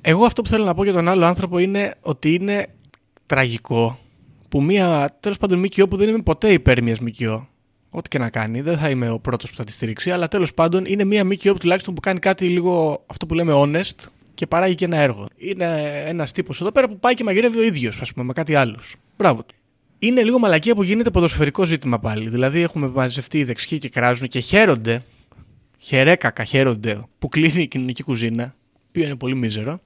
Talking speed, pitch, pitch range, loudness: 210 wpm, 150 Hz, 125-185 Hz, -19 LUFS